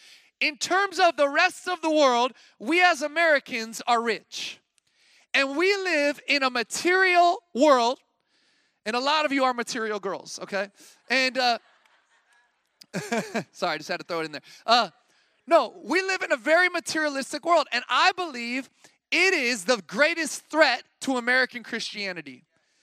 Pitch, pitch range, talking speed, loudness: 280 Hz, 240-335 Hz, 155 wpm, -24 LUFS